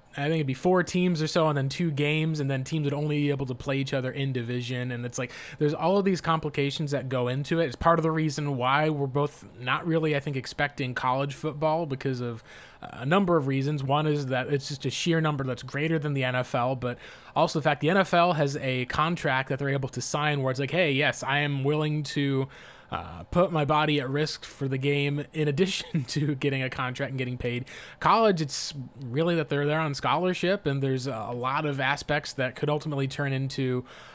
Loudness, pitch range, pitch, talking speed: -27 LUFS, 130-155 Hz, 145 Hz, 230 wpm